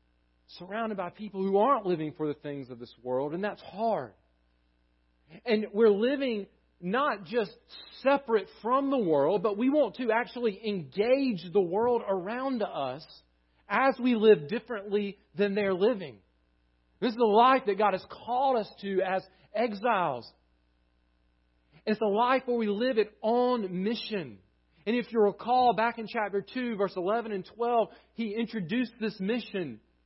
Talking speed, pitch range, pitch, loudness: 155 wpm, 170-235 Hz, 210 Hz, -29 LUFS